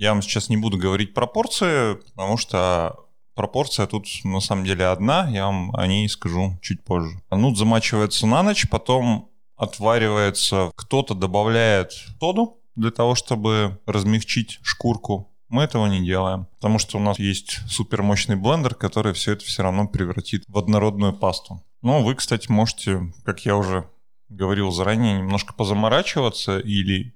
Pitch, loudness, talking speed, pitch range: 105 Hz, -21 LUFS, 150 wpm, 95-115 Hz